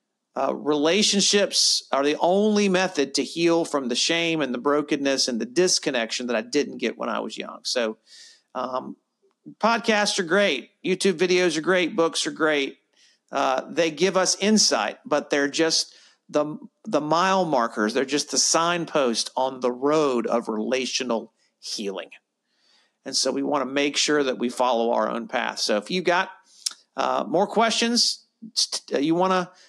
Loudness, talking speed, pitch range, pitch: -23 LUFS, 165 wpm, 140-190 Hz, 165 Hz